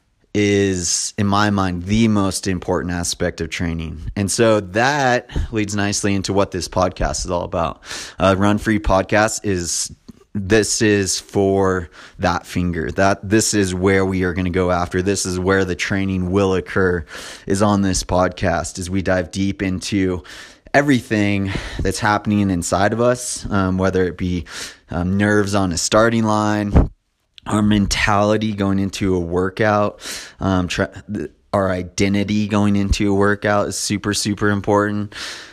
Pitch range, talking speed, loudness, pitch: 90-105 Hz, 155 wpm, -18 LUFS, 100 Hz